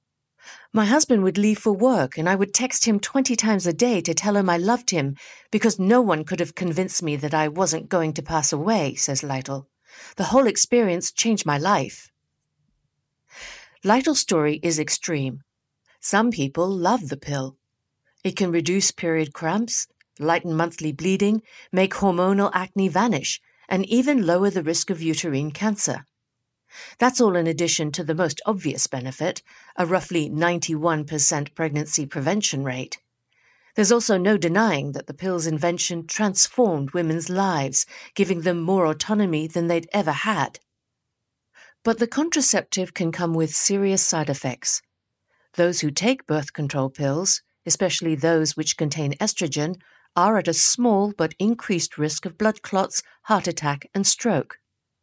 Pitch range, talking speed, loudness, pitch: 155-205 Hz, 155 wpm, -22 LUFS, 175 Hz